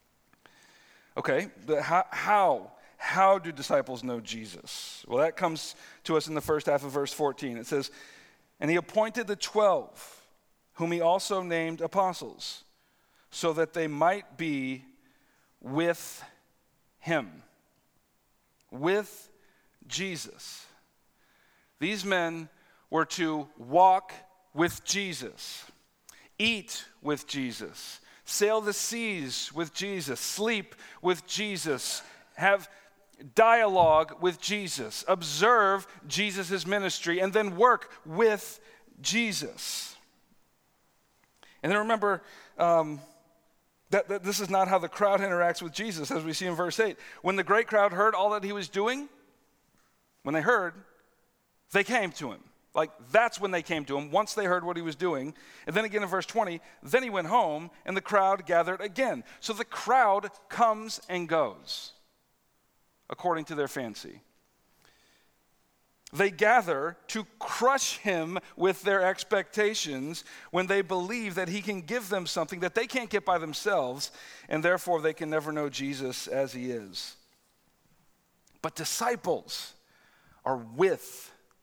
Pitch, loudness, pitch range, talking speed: 185 Hz, -29 LUFS, 160-205 Hz, 135 wpm